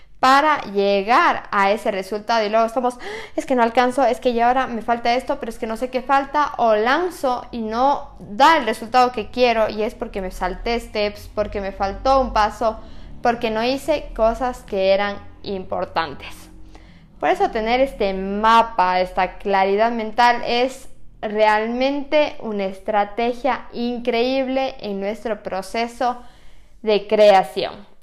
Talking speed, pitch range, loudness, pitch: 150 wpm, 210-255 Hz, -20 LUFS, 230 Hz